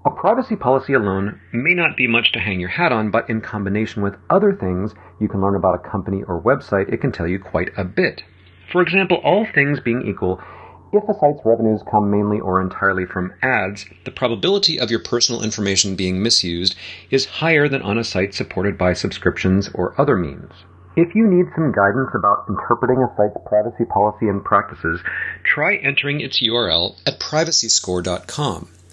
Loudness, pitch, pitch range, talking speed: -18 LUFS, 110 Hz, 95-135 Hz, 185 wpm